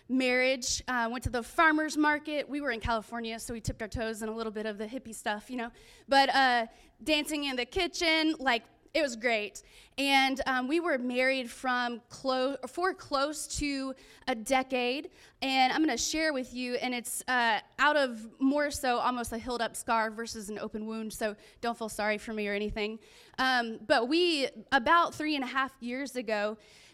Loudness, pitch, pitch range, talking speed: -30 LUFS, 255 Hz, 225-275 Hz, 200 wpm